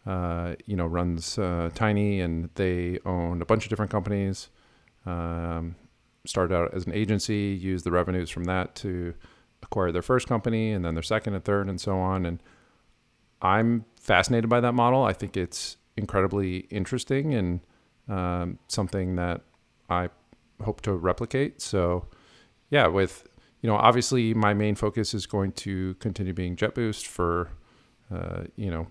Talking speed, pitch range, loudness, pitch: 160 wpm, 90-110 Hz, -27 LUFS, 95 Hz